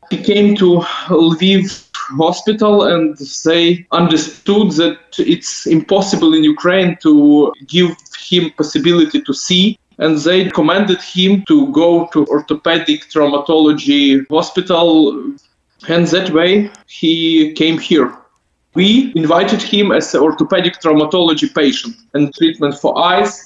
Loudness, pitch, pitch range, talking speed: -12 LUFS, 170 Hz, 155-195 Hz, 120 wpm